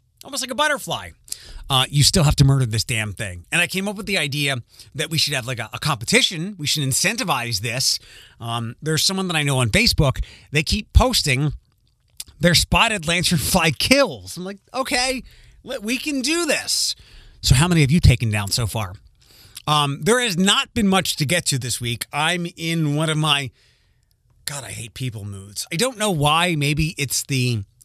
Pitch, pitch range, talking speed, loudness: 150 Hz, 120-180 Hz, 195 wpm, -19 LUFS